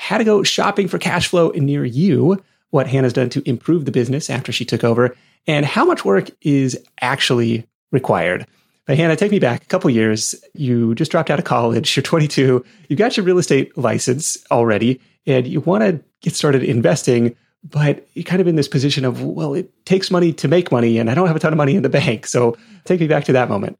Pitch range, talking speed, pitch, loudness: 125-175 Hz, 225 wpm, 145 Hz, -17 LUFS